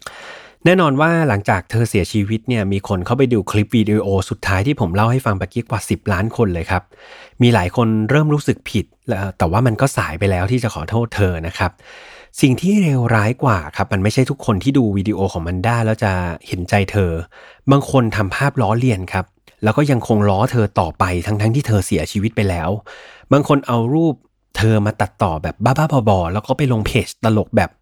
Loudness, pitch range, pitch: -17 LUFS, 100-125 Hz, 110 Hz